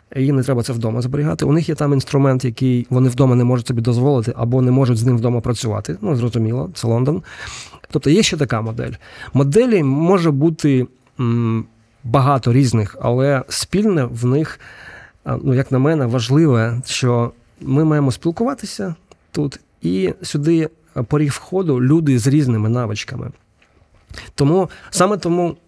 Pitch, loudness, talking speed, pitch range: 130 Hz, -17 LUFS, 150 wpm, 120-155 Hz